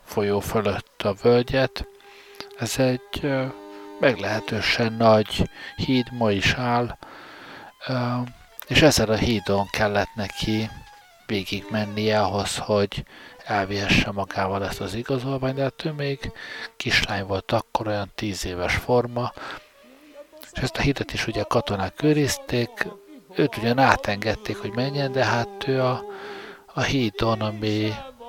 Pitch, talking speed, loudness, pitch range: 115 Hz, 125 wpm, -24 LUFS, 100-130 Hz